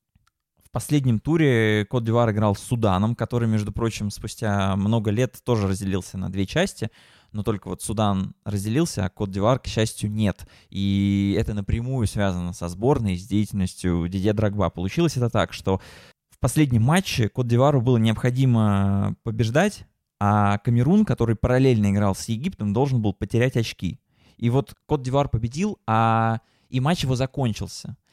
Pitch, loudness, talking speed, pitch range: 110 Hz, -23 LUFS, 155 wpm, 100-125 Hz